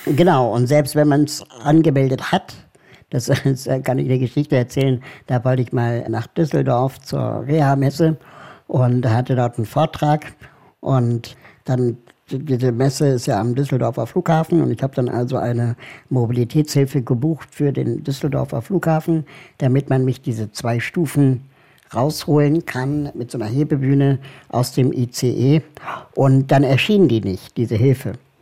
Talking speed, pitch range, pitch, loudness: 150 wpm, 125-145 Hz, 135 Hz, -19 LUFS